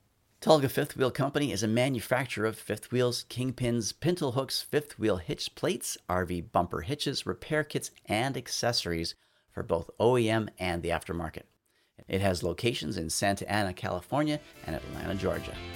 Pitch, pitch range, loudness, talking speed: 110 Hz, 90-130 Hz, -30 LUFS, 150 wpm